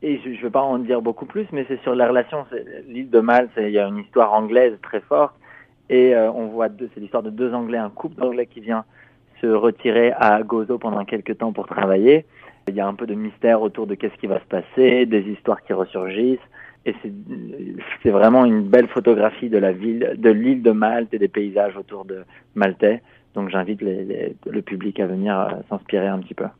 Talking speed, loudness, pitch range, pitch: 230 wpm, -19 LUFS, 105-125 Hz, 115 Hz